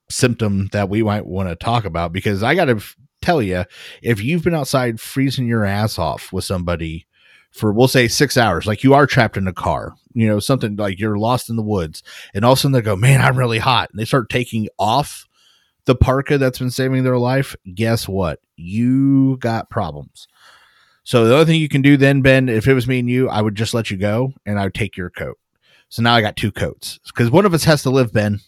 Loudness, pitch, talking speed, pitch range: -17 LUFS, 115 Hz, 240 wpm, 105-130 Hz